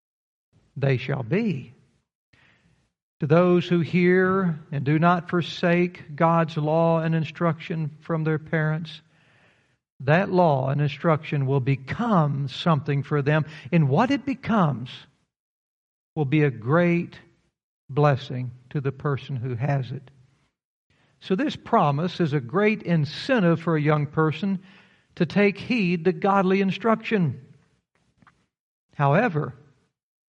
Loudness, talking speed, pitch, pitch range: -23 LUFS, 120 wpm, 155 Hz, 145-175 Hz